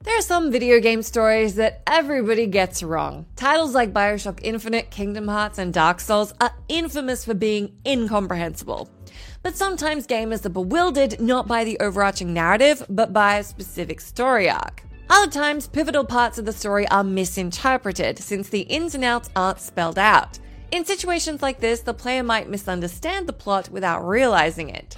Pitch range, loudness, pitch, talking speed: 200-275 Hz, -21 LUFS, 225 Hz, 170 wpm